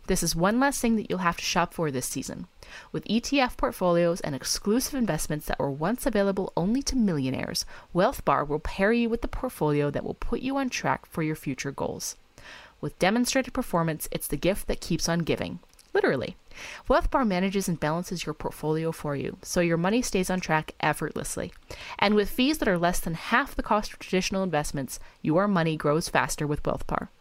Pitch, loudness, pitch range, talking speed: 180 Hz, -27 LUFS, 155-230 Hz, 195 wpm